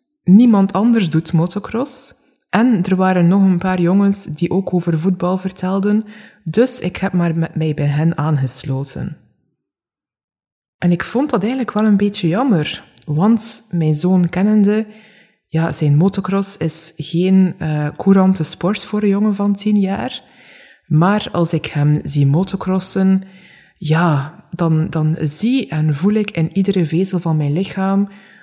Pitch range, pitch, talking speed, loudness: 165-205 Hz, 185 Hz, 150 wpm, -16 LUFS